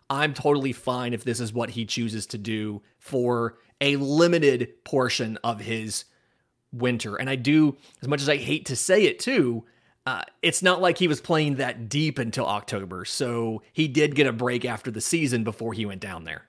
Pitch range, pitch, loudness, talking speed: 115-145 Hz, 125 Hz, -25 LUFS, 200 wpm